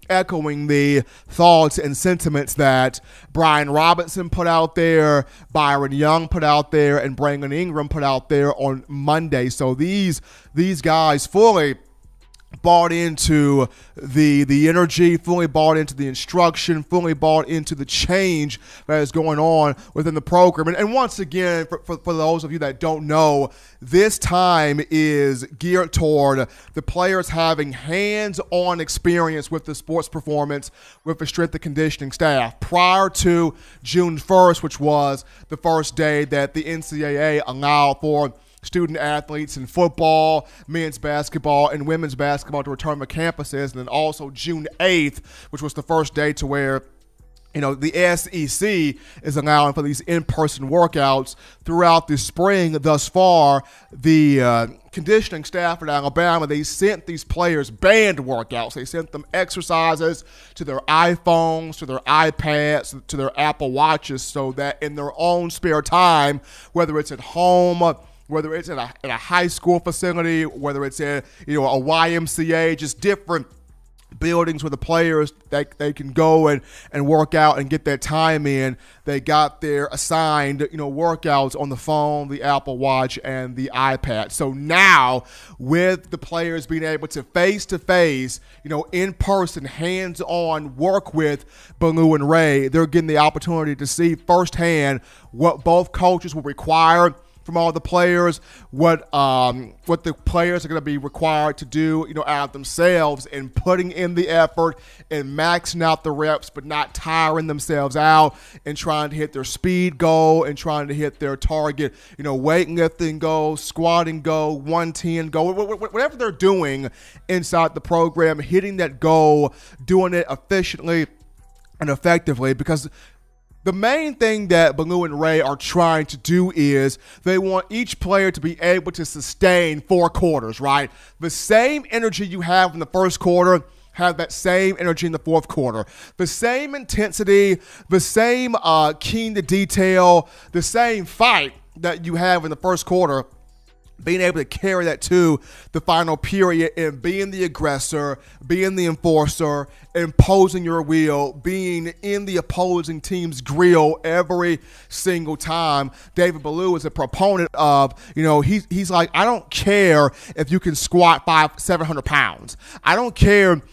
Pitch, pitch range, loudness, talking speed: 160 Hz, 145-175 Hz, -19 LUFS, 160 wpm